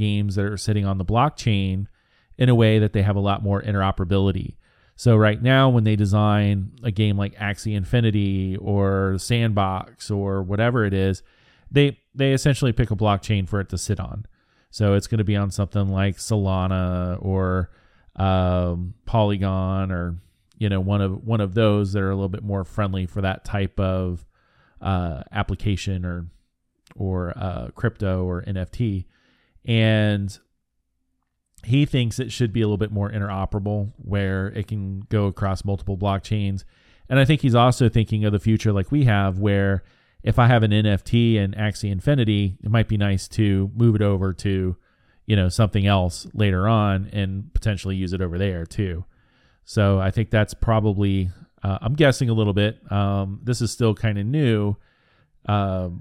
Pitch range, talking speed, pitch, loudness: 95-110 Hz, 175 wpm, 100 Hz, -22 LUFS